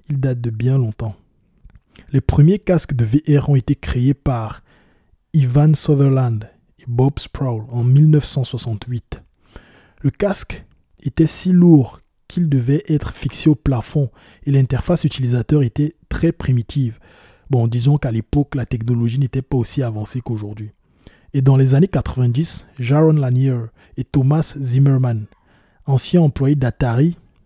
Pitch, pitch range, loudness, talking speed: 130 Hz, 115-145 Hz, -17 LUFS, 135 wpm